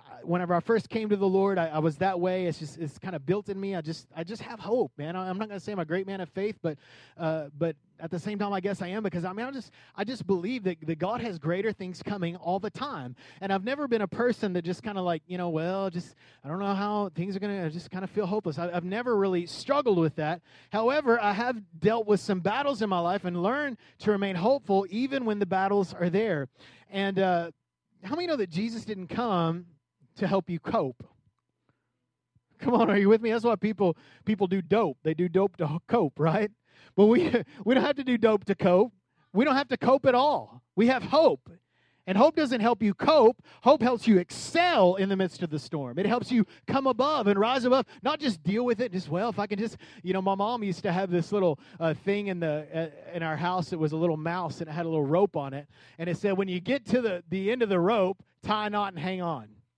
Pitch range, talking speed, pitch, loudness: 170-220 Hz, 260 wpm, 195 Hz, -28 LUFS